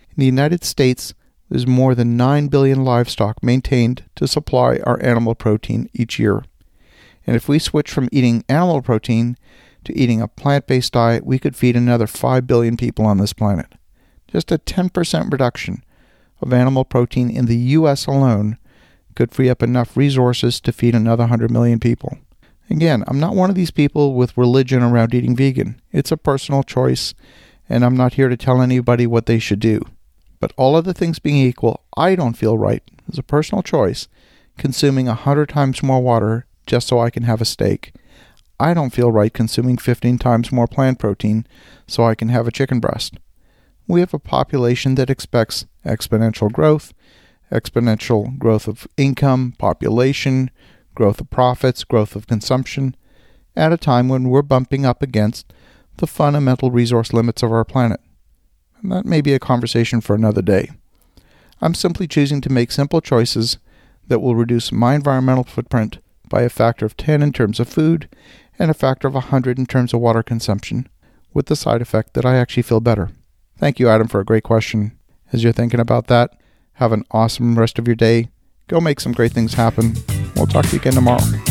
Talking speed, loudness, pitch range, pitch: 185 wpm, -17 LUFS, 115-135 Hz, 120 Hz